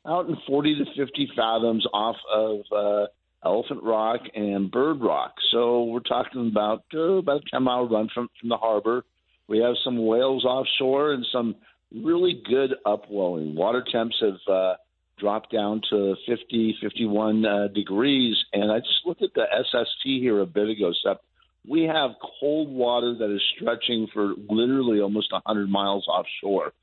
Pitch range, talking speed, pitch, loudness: 105-130 Hz, 165 wpm, 115 Hz, -24 LUFS